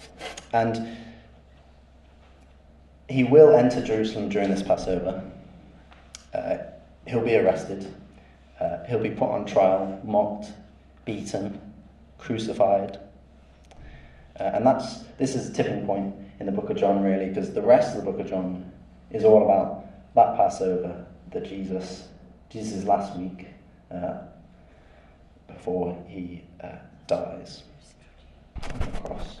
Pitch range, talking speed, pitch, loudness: 75-100 Hz, 125 wpm, 95 Hz, -24 LUFS